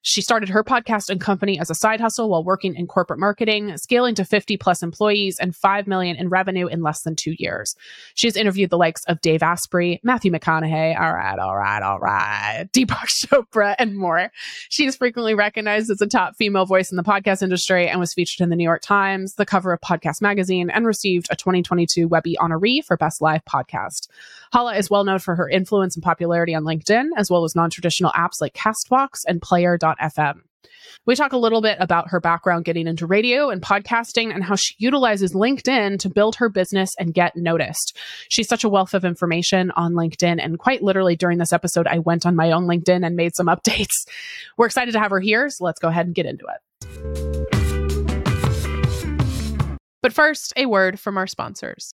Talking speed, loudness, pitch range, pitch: 200 wpm, -19 LUFS, 170-215 Hz, 185 Hz